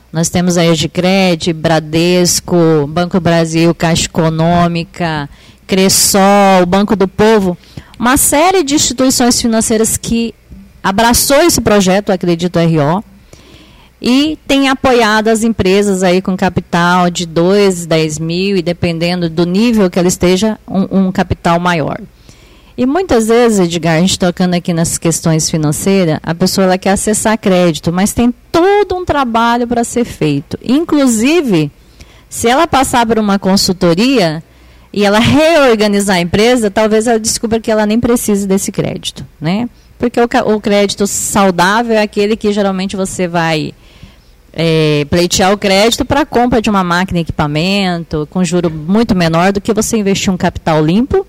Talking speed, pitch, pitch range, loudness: 150 wpm, 195 Hz, 175-230 Hz, -11 LUFS